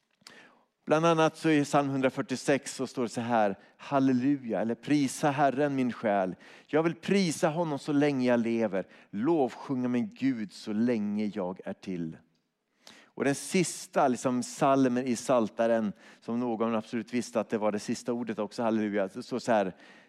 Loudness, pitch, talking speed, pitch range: -29 LUFS, 130 Hz, 170 wpm, 115-145 Hz